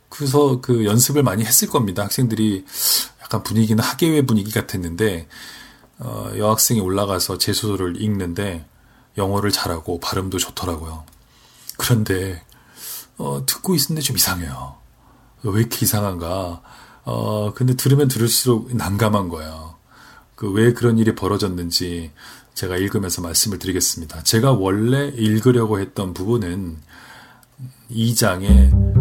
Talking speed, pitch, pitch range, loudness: 300 characters per minute, 105 Hz, 90-120 Hz, -19 LUFS